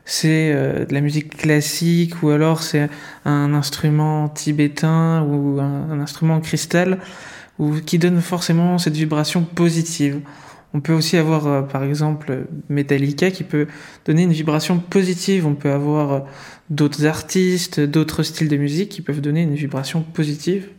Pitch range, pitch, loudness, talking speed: 145-165 Hz, 155 Hz, -19 LUFS, 145 wpm